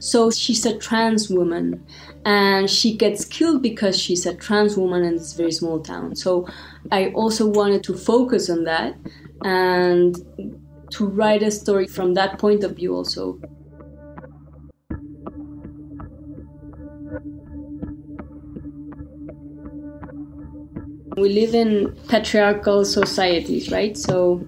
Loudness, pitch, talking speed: -19 LUFS, 180 Hz, 110 wpm